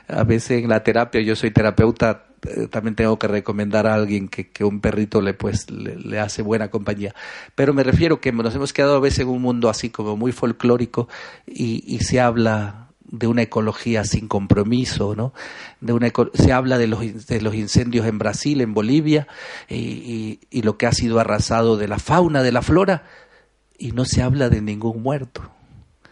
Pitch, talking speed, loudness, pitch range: 115 Hz, 195 wpm, -20 LUFS, 110-125 Hz